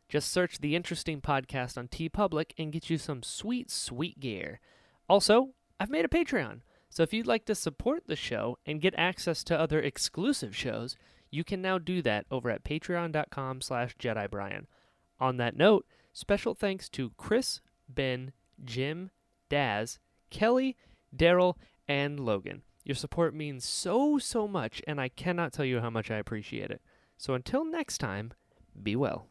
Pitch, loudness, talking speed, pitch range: 155 Hz, -31 LUFS, 165 wpm, 130-190 Hz